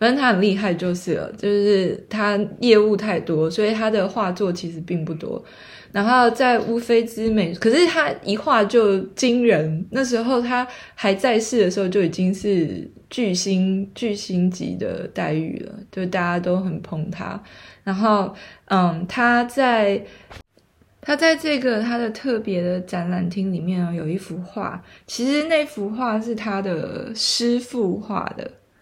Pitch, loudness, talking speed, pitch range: 205 Hz, -21 LUFS, 225 characters per minute, 180-235 Hz